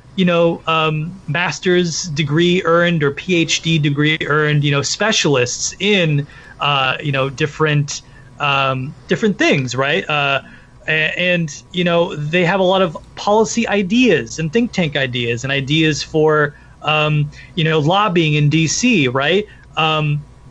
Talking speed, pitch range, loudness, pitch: 140 wpm, 140-175 Hz, -16 LUFS, 155 Hz